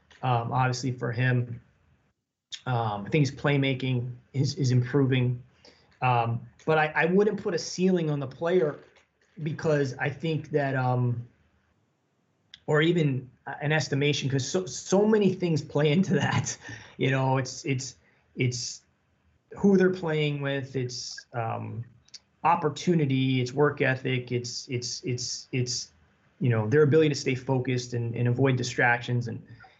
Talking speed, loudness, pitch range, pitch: 145 wpm, -27 LUFS, 120-150 Hz, 130 Hz